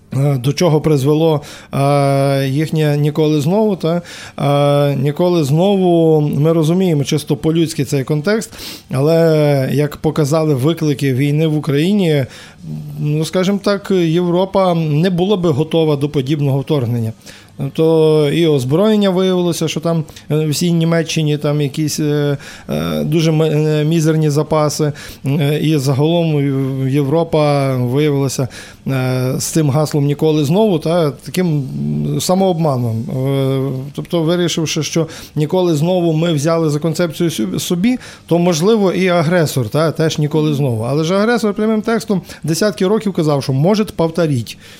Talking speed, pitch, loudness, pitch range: 125 wpm, 155 Hz, -15 LUFS, 145-170 Hz